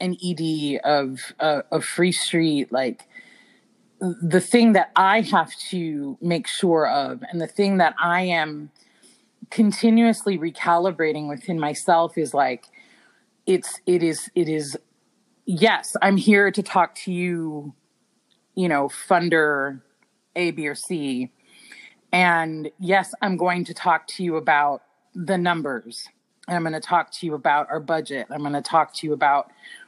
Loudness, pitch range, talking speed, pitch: -22 LUFS, 150-190 Hz, 155 wpm, 170 Hz